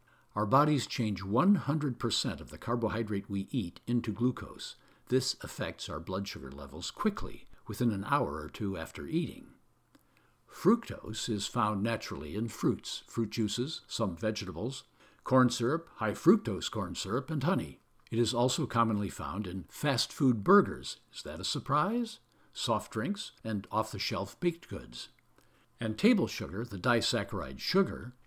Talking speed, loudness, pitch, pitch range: 150 wpm, -32 LUFS, 115 Hz, 100-125 Hz